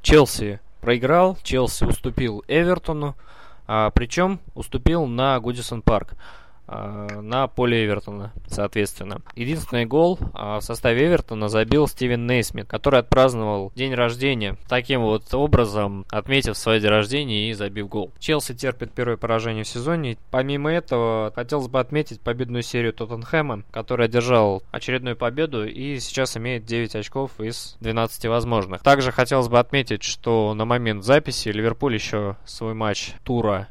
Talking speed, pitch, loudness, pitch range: 135 wpm, 120 Hz, -22 LUFS, 110-130 Hz